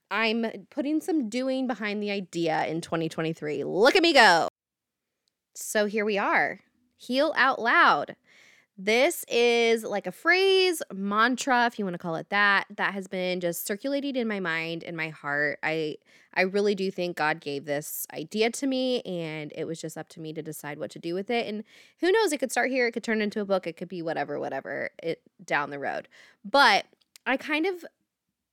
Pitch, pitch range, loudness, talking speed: 205 Hz, 170-250 Hz, -26 LUFS, 200 wpm